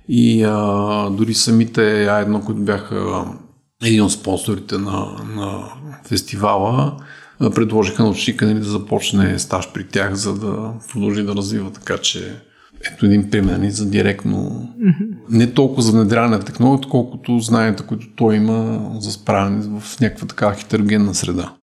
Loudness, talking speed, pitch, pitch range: -17 LUFS, 140 wpm, 105 Hz, 100-115 Hz